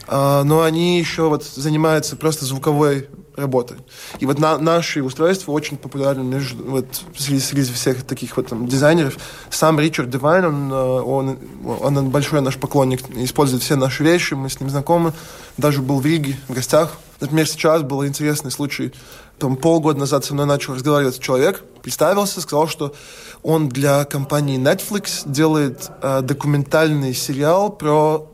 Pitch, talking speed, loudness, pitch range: 145 Hz, 155 wpm, -18 LUFS, 135-155 Hz